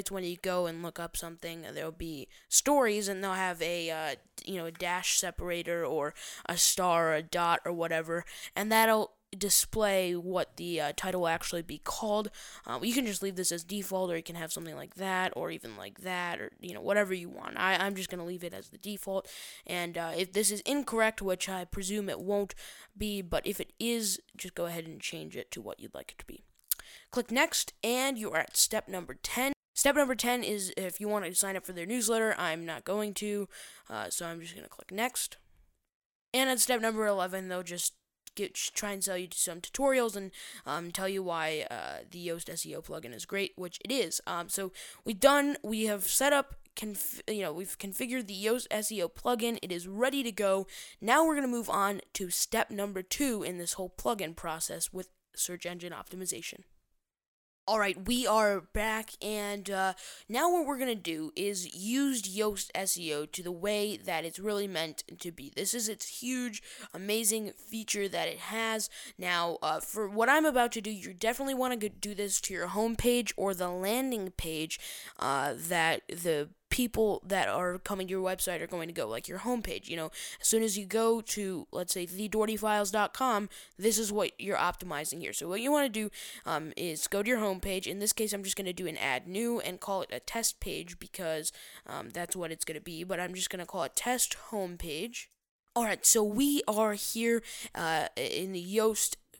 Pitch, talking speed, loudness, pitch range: 195 Hz, 215 wpm, -32 LUFS, 175-220 Hz